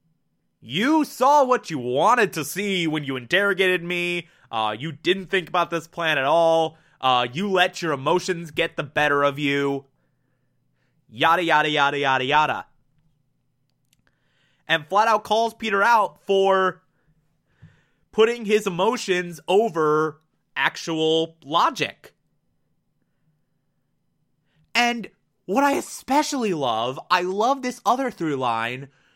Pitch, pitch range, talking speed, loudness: 165 Hz, 150-195 Hz, 120 wpm, -22 LUFS